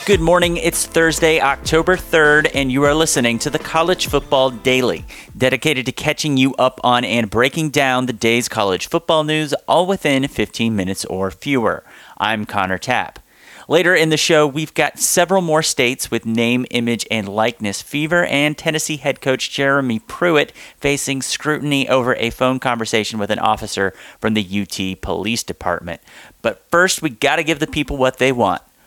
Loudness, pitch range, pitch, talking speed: -17 LUFS, 115-155 Hz, 135 Hz, 175 wpm